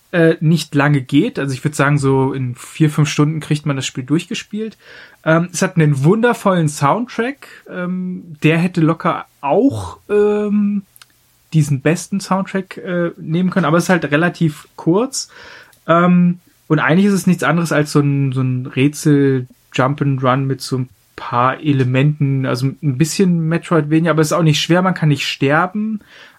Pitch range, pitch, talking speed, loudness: 140-180 Hz, 155 Hz, 160 wpm, -16 LUFS